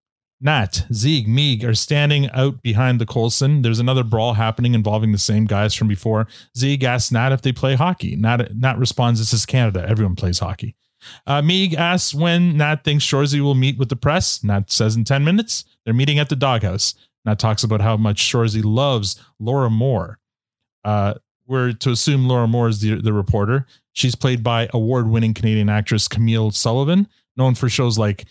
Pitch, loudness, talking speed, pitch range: 120 Hz, -18 LUFS, 185 wpm, 110-135 Hz